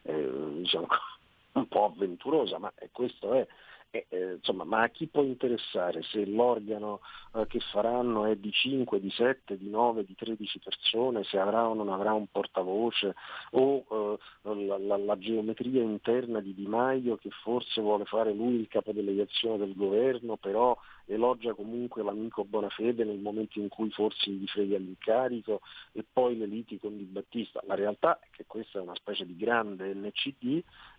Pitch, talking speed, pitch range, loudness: 110 Hz, 170 wpm, 105-120 Hz, -31 LUFS